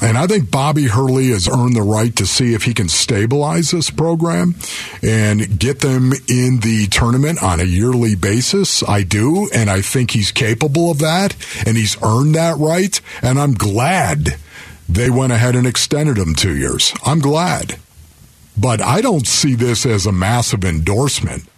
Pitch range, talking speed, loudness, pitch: 105-145 Hz, 175 wpm, -15 LUFS, 120 Hz